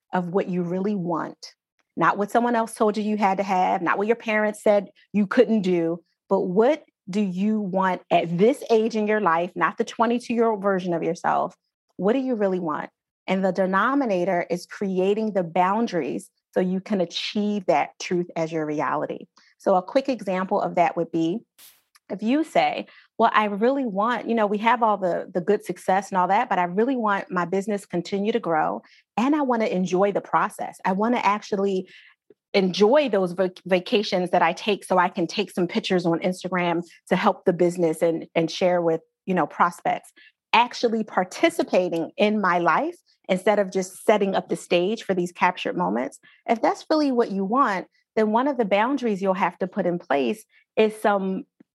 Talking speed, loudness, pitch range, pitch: 200 wpm, -23 LUFS, 180-225 Hz, 200 Hz